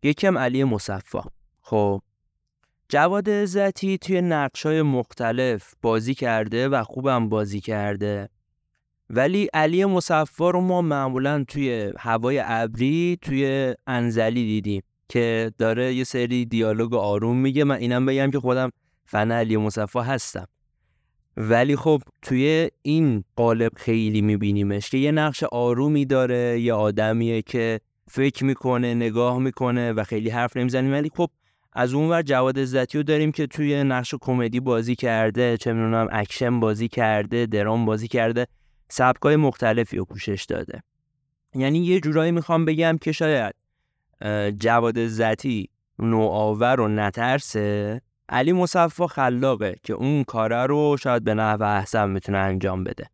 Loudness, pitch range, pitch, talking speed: -22 LUFS, 110-140 Hz, 125 Hz, 135 wpm